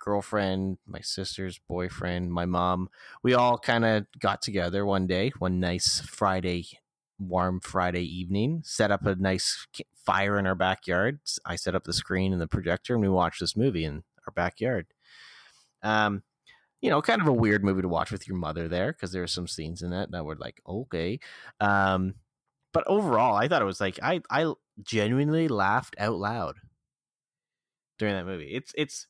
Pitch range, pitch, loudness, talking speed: 90-110 Hz, 95 Hz, -28 LUFS, 180 wpm